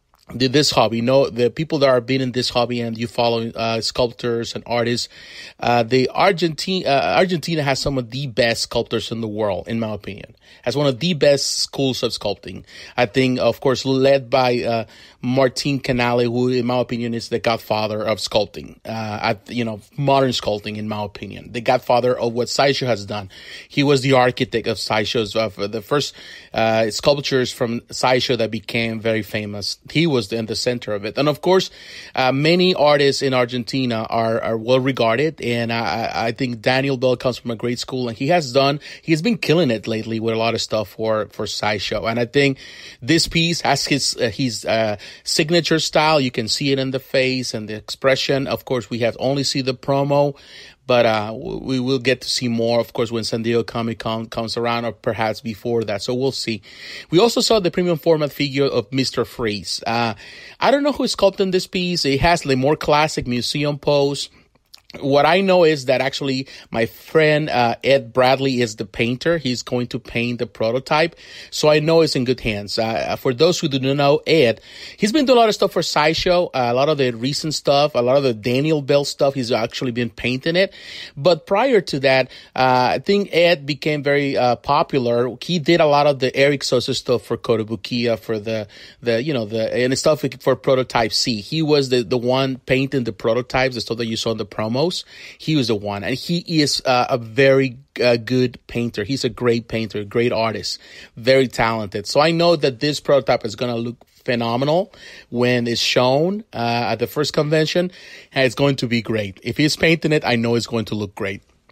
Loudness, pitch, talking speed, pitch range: -19 LUFS, 125 Hz, 215 wpm, 115-145 Hz